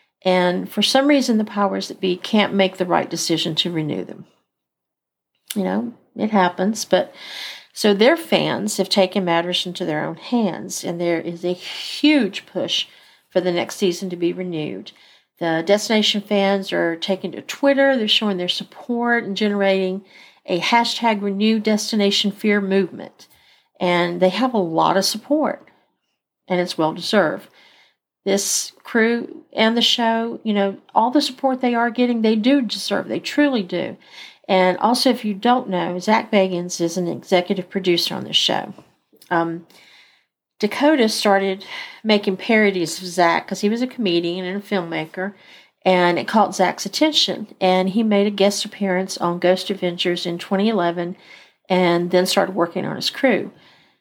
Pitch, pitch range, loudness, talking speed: 195 Hz, 180-220 Hz, -19 LUFS, 160 wpm